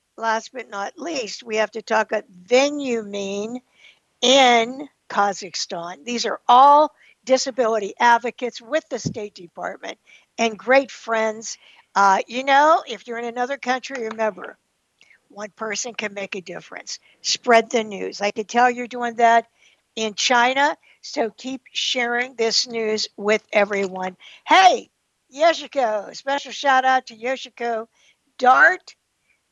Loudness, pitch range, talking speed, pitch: -20 LUFS, 215-255 Hz, 135 wpm, 235 Hz